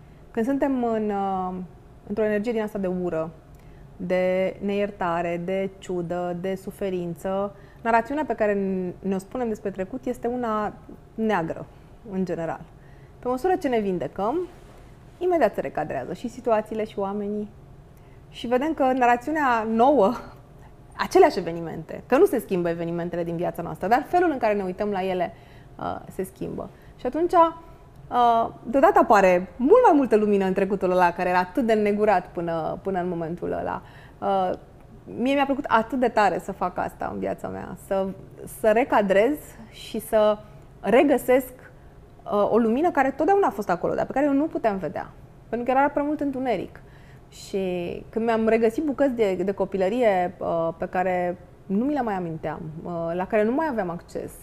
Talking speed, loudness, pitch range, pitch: 160 wpm, -24 LUFS, 175-240 Hz, 200 Hz